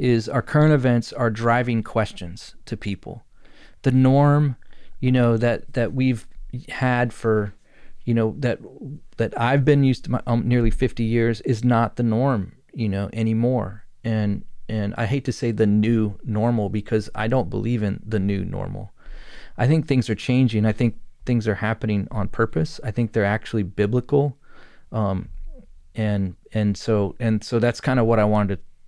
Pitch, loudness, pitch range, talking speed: 115 Hz, -22 LUFS, 105-125 Hz, 175 wpm